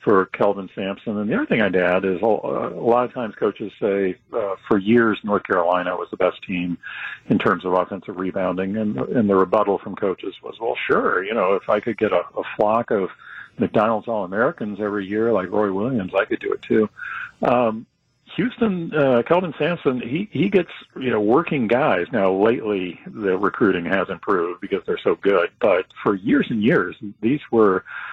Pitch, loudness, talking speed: 110 Hz, -21 LUFS, 190 wpm